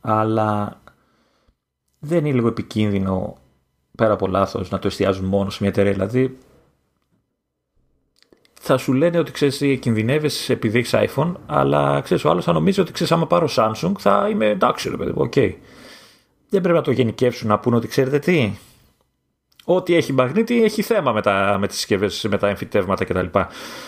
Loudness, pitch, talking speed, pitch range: -19 LUFS, 110 Hz, 165 wpm, 100-140 Hz